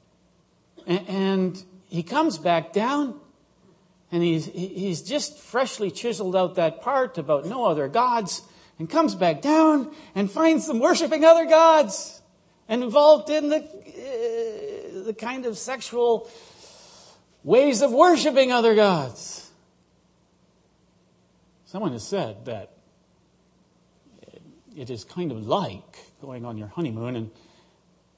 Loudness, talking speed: -22 LUFS, 120 wpm